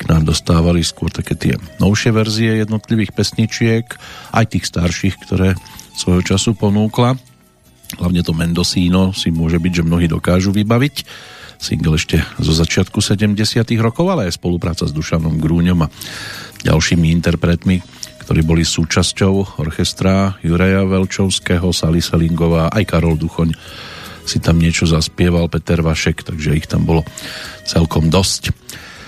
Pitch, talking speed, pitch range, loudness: 90 Hz, 130 wpm, 85-105 Hz, -15 LUFS